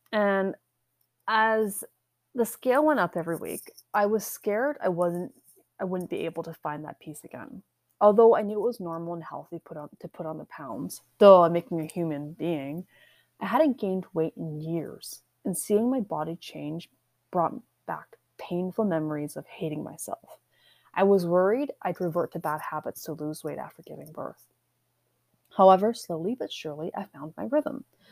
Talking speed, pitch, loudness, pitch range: 175 wpm, 175 Hz, -27 LUFS, 155-210 Hz